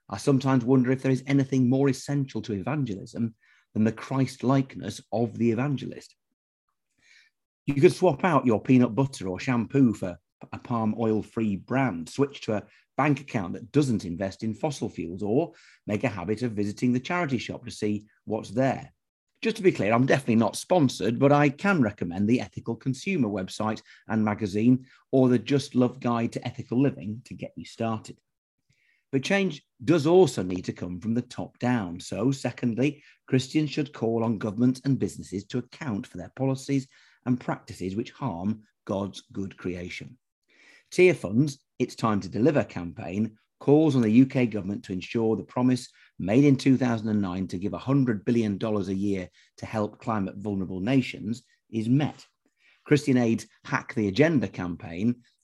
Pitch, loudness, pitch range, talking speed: 120 Hz, -26 LUFS, 105-135 Hz, 170 wpm